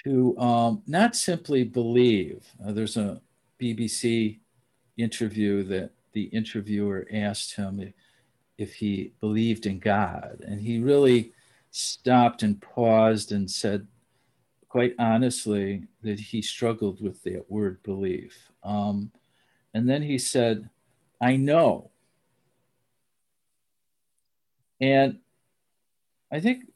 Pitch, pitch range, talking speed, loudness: 115 Hz, 105-125 Hz, 110 wpm, -26 LUFS